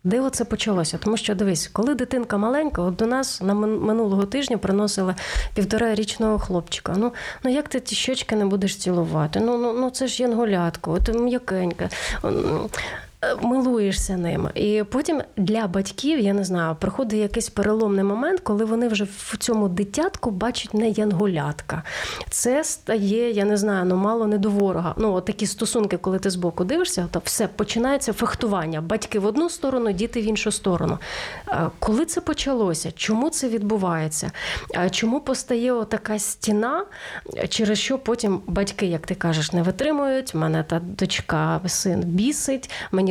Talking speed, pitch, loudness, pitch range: 160 wpm, 215 Hz, -23 LUFS, 190-235 Hz